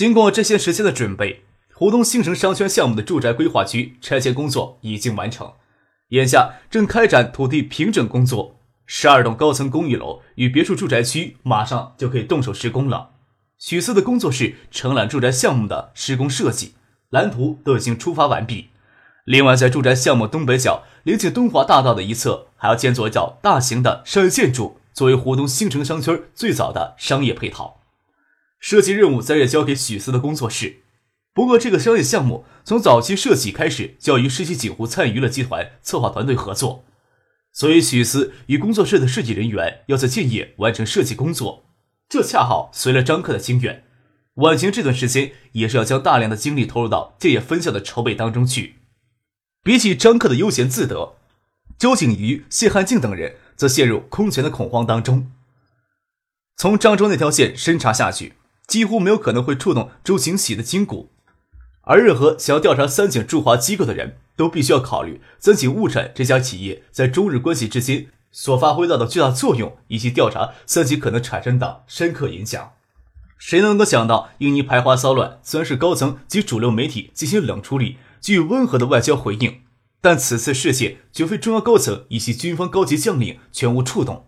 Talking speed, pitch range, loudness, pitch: 295 characters per minute, 120-160 Hz, -18 LUFS, 130 Hz